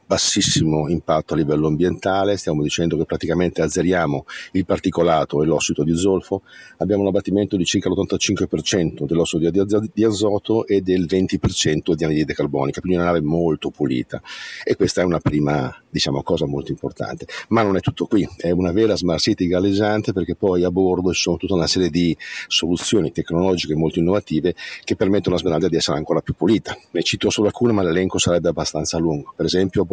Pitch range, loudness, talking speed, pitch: 85-100 Hz, -19 LUFS, 180 wpm, 90 Hz